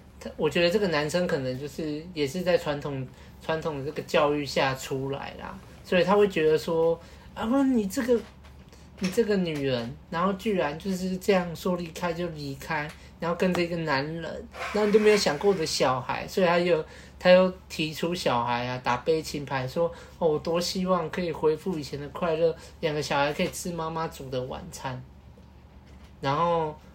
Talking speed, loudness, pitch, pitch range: 270 characters per minute, -27 LUFS, 165 Hz, 145-180 Hz